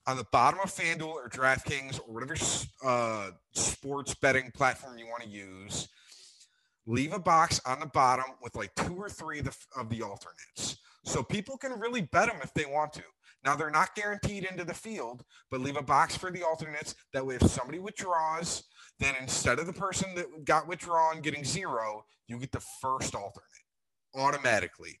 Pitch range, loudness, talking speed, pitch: 130-170 Hz, -31 LUFS, 185 wpm, 145 Hz